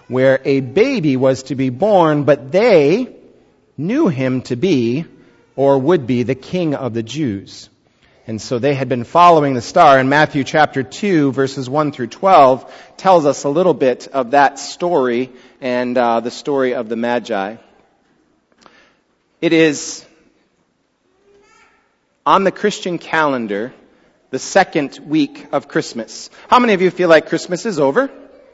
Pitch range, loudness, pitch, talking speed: 130-180 Hz, -15 LUFS, 140 Hz, 150 wpm